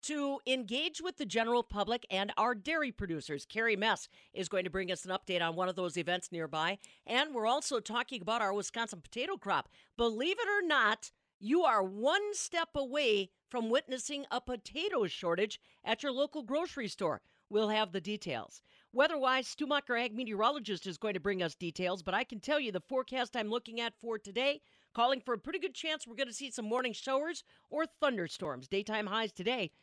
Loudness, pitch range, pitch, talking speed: -35 LUFS, 200-280 Hz, 235 Hz, 195 wpm